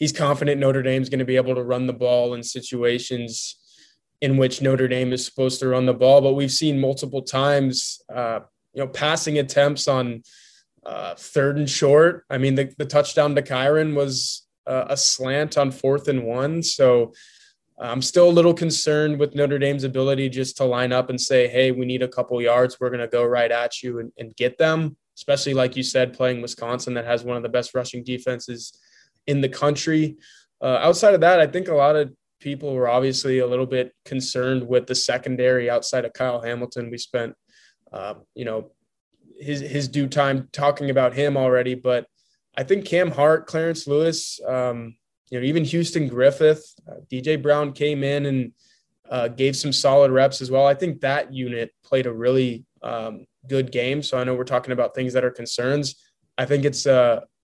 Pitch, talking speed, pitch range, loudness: 135 Hz, 200 wpm, 125-145 Hz, -21 LUFS